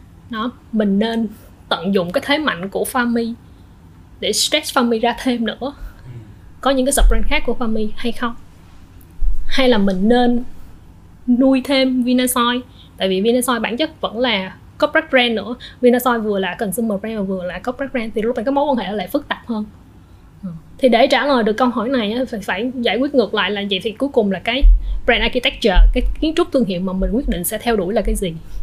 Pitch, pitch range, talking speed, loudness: 235 Hz, 200-255 Hz, 210 wpm, -18 LUFS